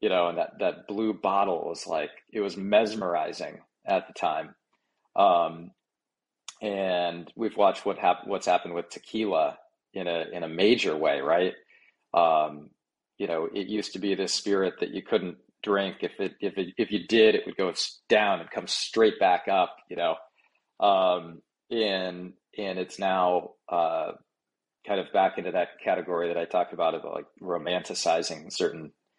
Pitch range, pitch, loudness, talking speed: 90-100 Hz, 95 Hz, -27 LUFS, 170 wpm